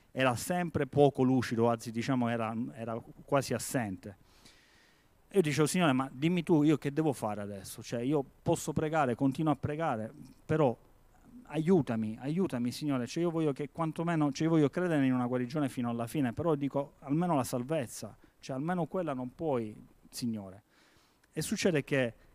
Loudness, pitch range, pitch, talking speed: -32 LUFS, 120-155 Hz, 140 Hz, 165 wpm